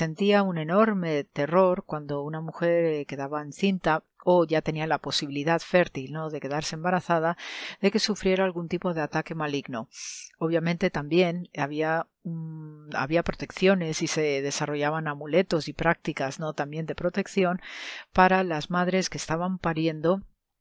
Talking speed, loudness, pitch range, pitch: 145 wpm, -27 LUFS, 150-180 Hz, 165 Hz